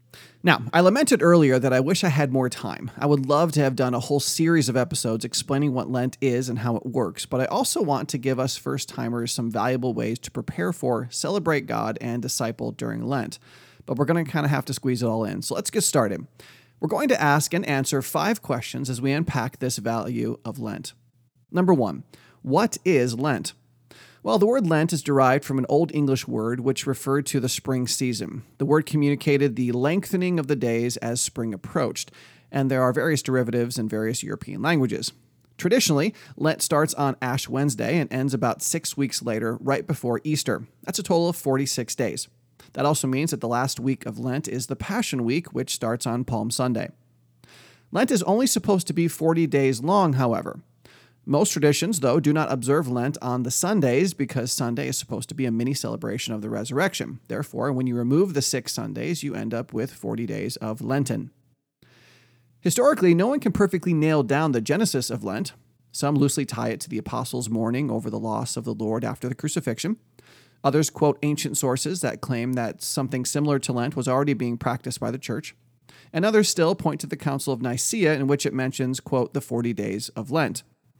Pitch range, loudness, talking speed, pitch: 120-150 Hz, -24 LUFS, 205 wpm, 135 Hz